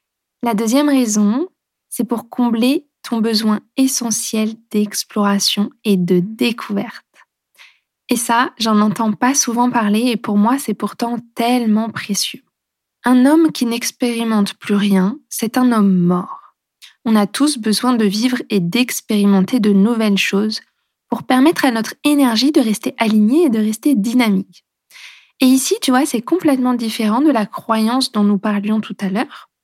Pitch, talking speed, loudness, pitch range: 230 Hz, 155 wpm, -16 LUFS, 210-255 Hz